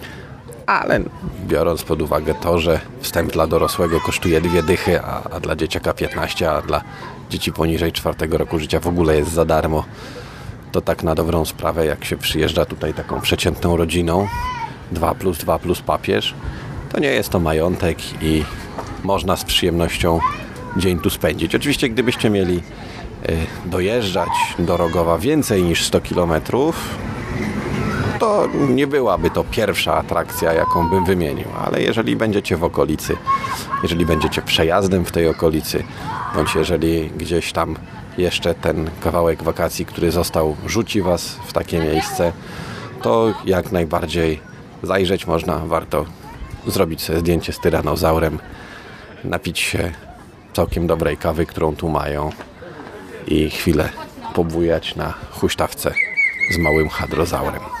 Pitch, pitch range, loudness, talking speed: 85 Hz, 80-95 Hz, -19 LUFS, 135 wpm